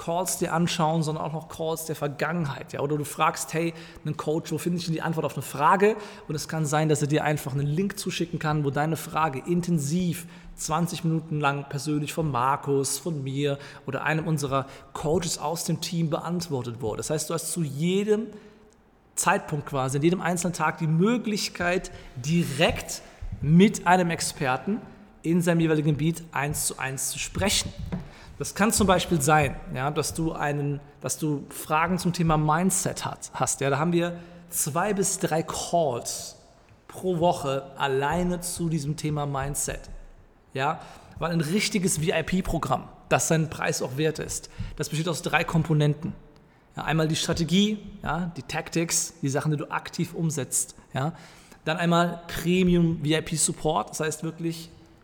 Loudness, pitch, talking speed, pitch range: -26 LUFS, 160 Hz, 170 wpm, 150-175 Hz